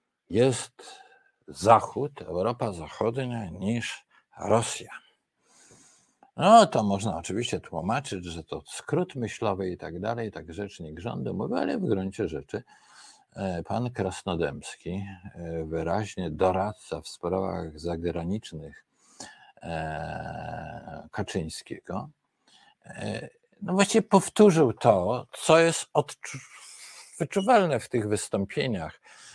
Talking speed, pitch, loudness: 90 wpm, 105 Hz, -27 LUFS